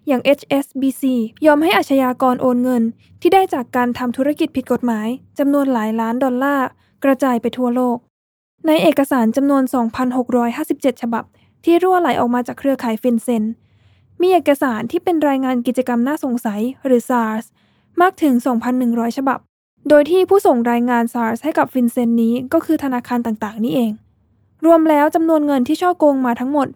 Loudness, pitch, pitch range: -17 LUFS, 260 Hz, 240-295 Hz